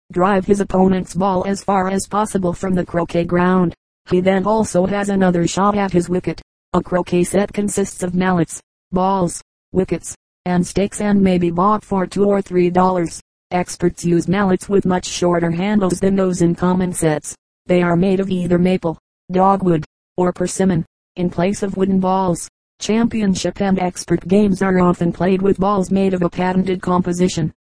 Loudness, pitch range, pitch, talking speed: -17 LUFS, 175-195 Hz, 185 Hz, 175 wpm